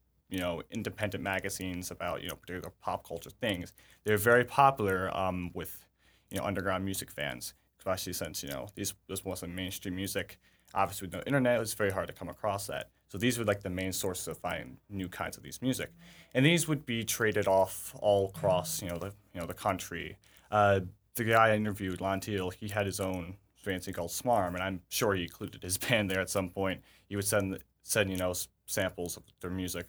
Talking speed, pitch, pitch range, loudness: 215 wpm, 95 Hz, 90-105 Hz, -32 LUFS